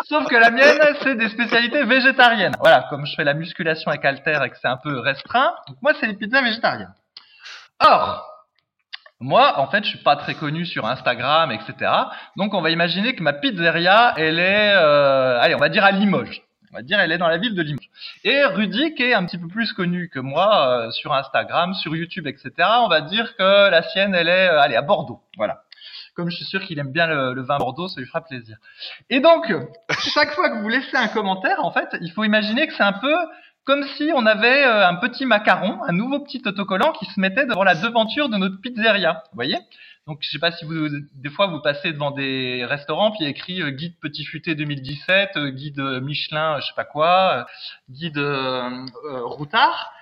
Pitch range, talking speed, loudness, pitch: 150-235 Hz, 220 wpm, -19 LUFS, 185 Hz